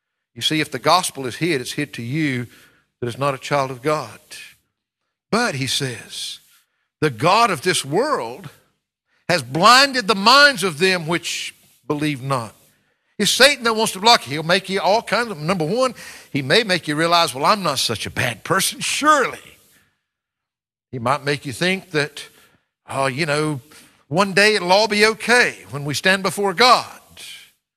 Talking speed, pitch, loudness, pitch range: 180 wpm, 170 Hz, -18 LUFS, 140-205 Hz